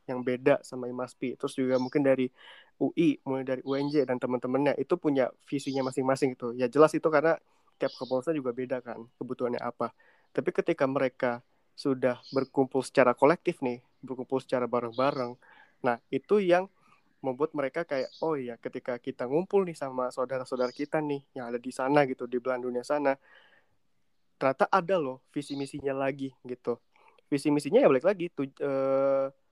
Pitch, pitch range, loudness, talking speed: 135 Hz, 125-145 Hz, -29 LUFS, 165 wpm